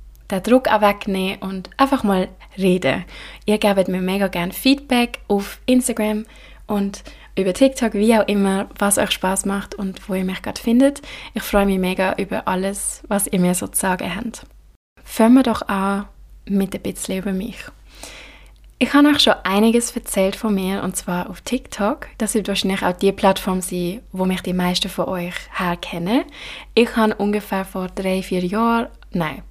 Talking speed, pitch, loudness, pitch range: 175 wpm, 200 Hz, -19 LUFS, 190-225 Hz